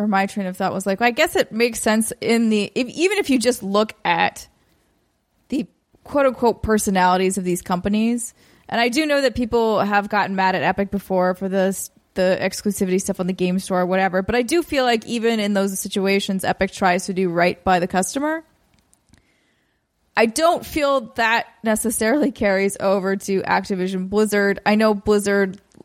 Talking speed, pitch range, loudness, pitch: 190 wpm, 190-230 Hz, -20 LUFS, 205 Hz